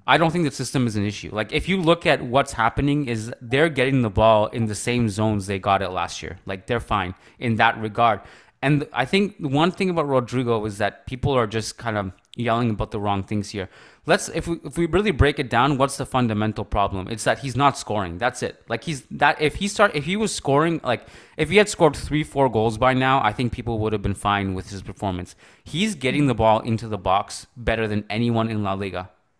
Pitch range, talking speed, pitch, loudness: 105-140 Hz, 240 wpm, 120 Hz, -22 LUFS